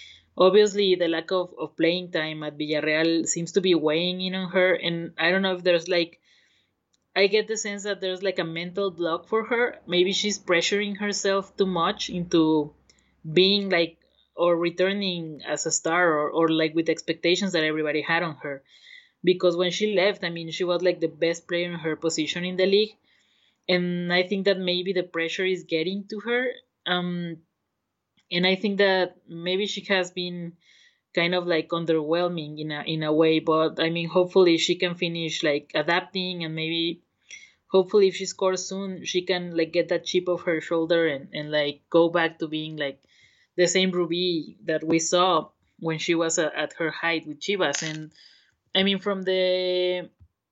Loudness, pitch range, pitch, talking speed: -24 LUFS, 165-185 Hz, 175 Hz, 190 wpm